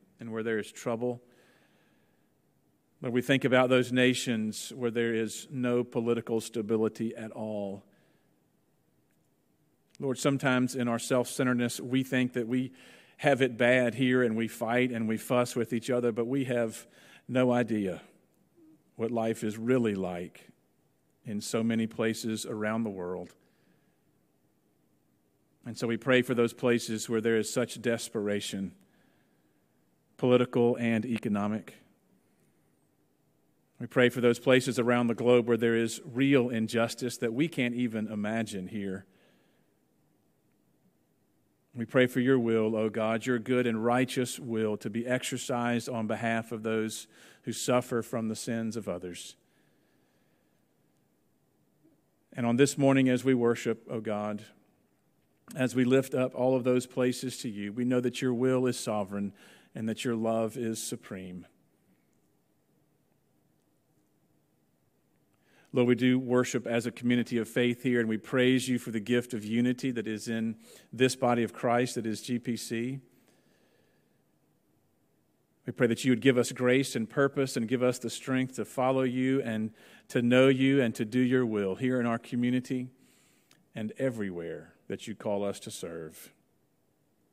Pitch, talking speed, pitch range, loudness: 120 Hz, 150 wpm, 110-125 Hz, -29 LUFS